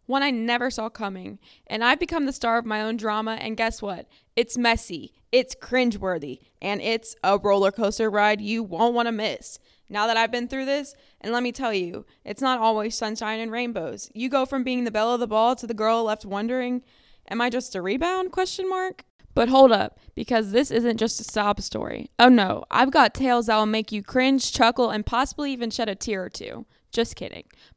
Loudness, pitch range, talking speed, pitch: -23 LUFS, 215-250 Hz, 220 wpm, 230 Hz